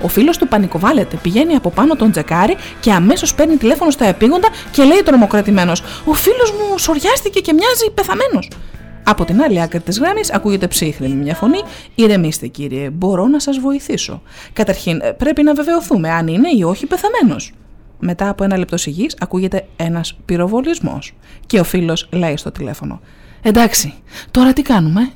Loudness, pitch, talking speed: -14 LUFS, 220 Hz, 160 wpm